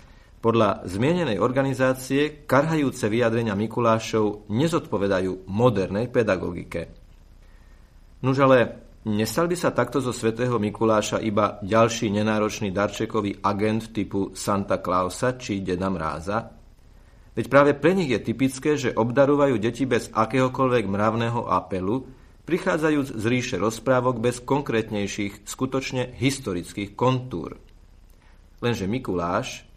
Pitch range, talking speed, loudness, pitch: 100-130 Hz, 105 wpm, -24 LUFS, 115 Hz